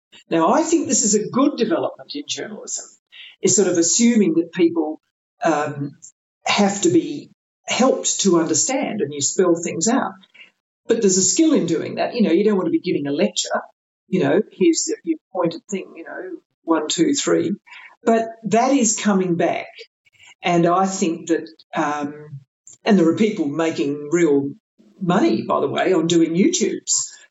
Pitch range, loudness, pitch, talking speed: 165-235 Hz, -19 LUFS, 190 Hz, 175 wpm